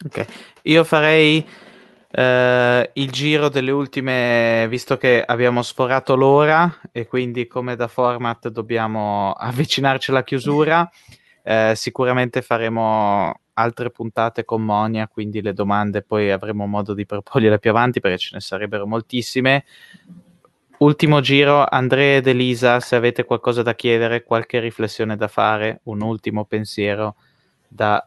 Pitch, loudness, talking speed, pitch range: 120 Hz, -18 LUFS, 135 wpm, 110-135 Hz